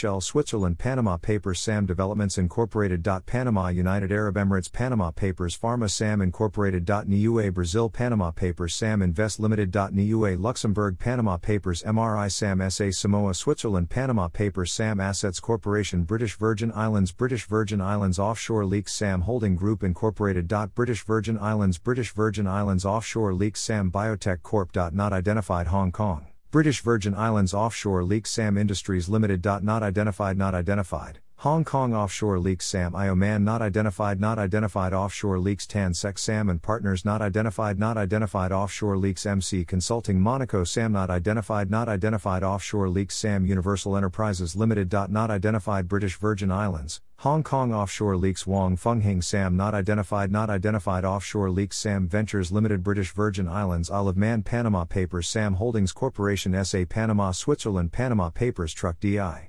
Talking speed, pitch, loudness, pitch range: 150 wpm, 100 Hz, -25 LUFS, 95-110 Hz